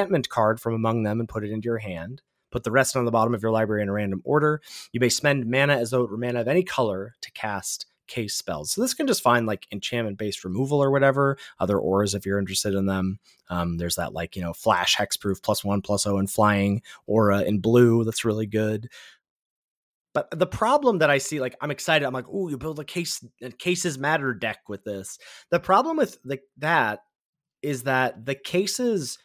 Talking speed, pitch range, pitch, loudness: 220 wpm, 105-145 Hz, 120 Hz, -24 LUFS